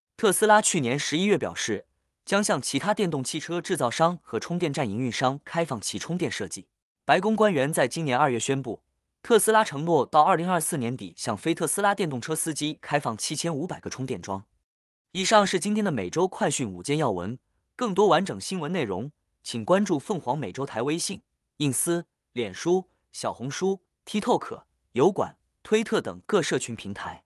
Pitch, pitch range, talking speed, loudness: 160 Hz, 130-190 Hz, 295 characters per minute, -26 LUFS